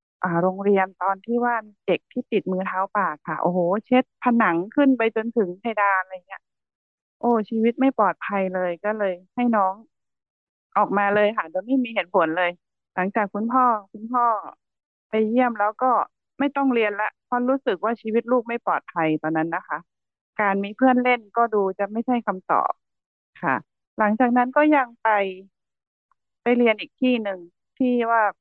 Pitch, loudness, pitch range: 215 Hz, -22 LUFS, 190-245 Hz